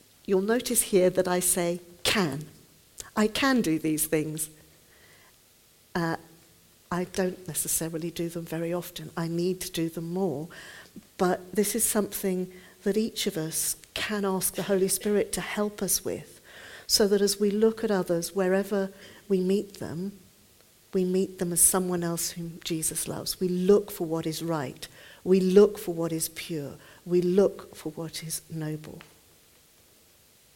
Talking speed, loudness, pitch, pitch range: 160 wpm, -27 LUFS, 180 Hz, 165-200 Hz